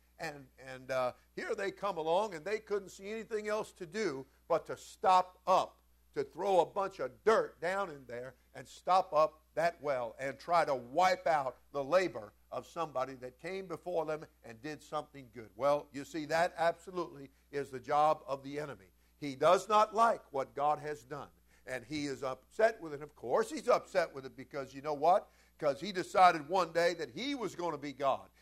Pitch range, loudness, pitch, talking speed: 135-180 Hz, -34 LUFS, 150 Hz, 205 wpm